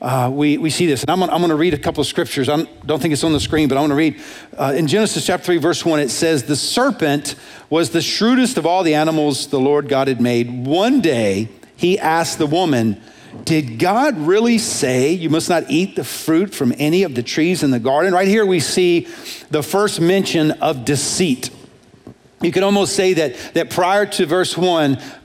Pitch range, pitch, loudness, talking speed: 145-180 Hz, 160 Hz, -17 LUFS, 220 wpm